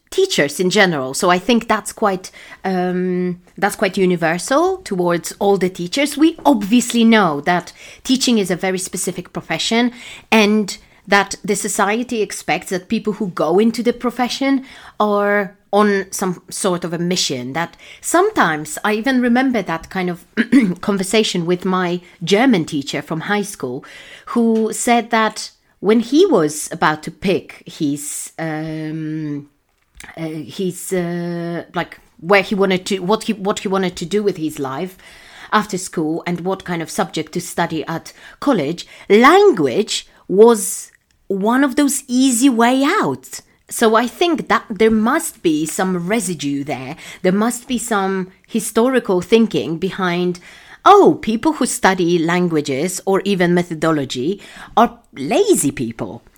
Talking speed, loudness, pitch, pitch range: 145 wpm, -17 LUFS, 195 Hz, 175-225 Hz